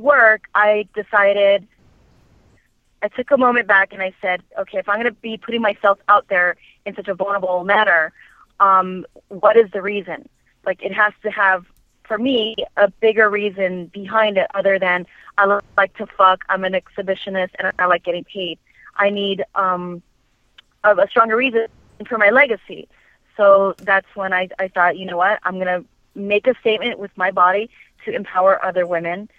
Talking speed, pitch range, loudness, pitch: 180 wpm, 185-210 Hz, -17 LUFS, 200 Hz